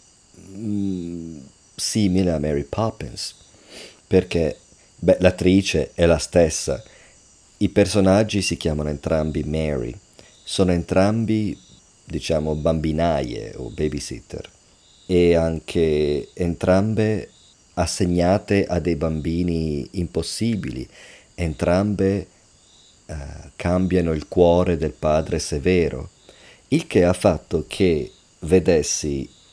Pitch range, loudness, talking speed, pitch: 80-95 Hz, -21 LUFS, 90 wpm, 85 Hz